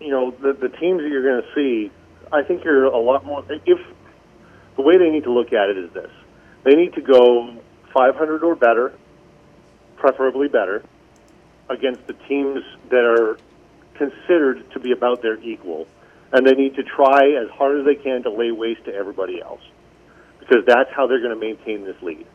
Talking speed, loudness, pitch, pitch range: 190 wpm, -18 LUFS, 135 Hz, 120-145 Hz